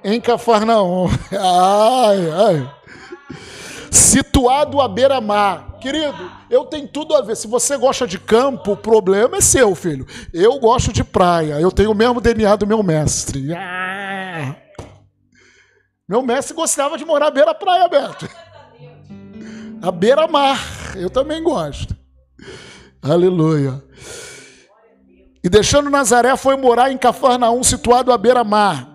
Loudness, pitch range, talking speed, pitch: -15 LUFS, 180-270 Hz, 120 wpm, 220 Hz